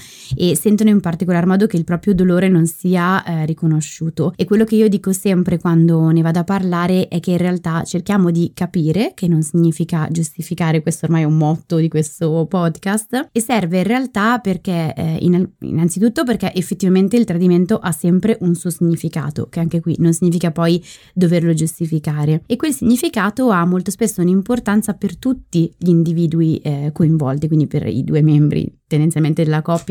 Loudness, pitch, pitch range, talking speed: -16 LUFS, 175 Hz, 165-195 Hz, 175 wpm